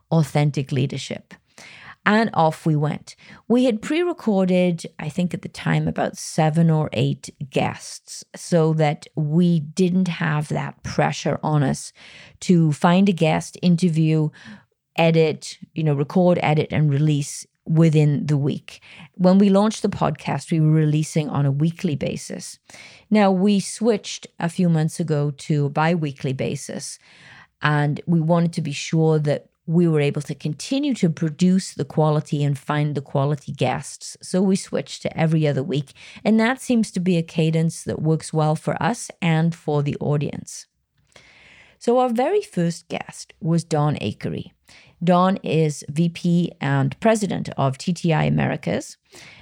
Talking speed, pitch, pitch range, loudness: 155 wpm, 160 Hz, 150-180 Hz, -21 LUFS